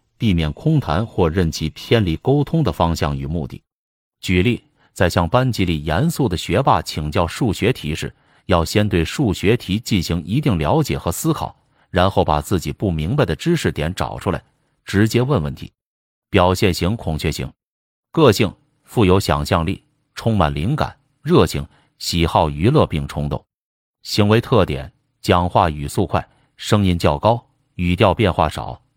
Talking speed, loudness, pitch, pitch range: 235 characters per minute, -19 LUFS, 95 Hz, 80-115 Hz